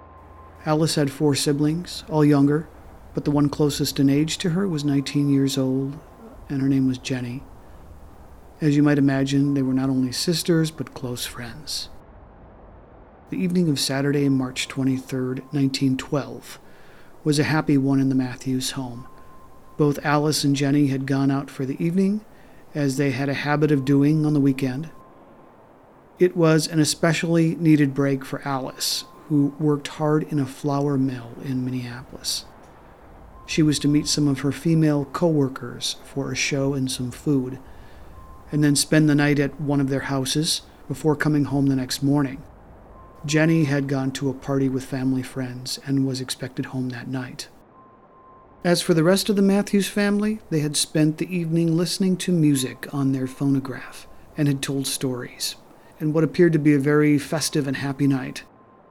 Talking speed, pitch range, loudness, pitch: 170 wpm, 135-155 Hz, -22 LUFS, 140 Hz